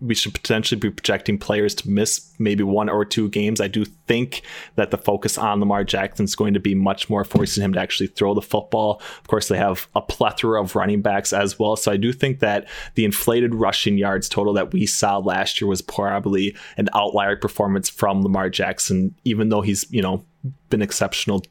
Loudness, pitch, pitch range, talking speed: -21 LUFS, 105 Hz, 100-110 Hz, 210 wpm